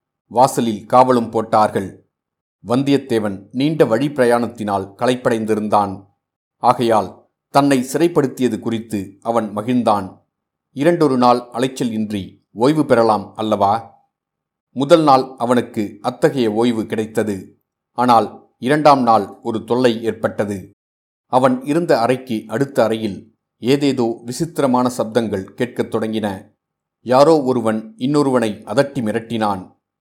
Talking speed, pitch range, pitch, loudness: 95 wpm, 105-130 Hz, 115 Hz, -17 LUFS